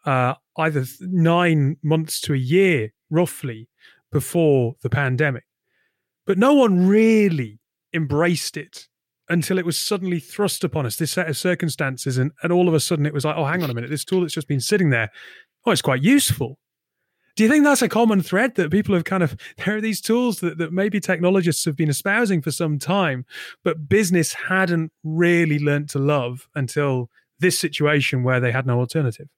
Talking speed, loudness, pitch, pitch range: 195 wpm, -20 LUFS, 165 Hz, 140-185 Hz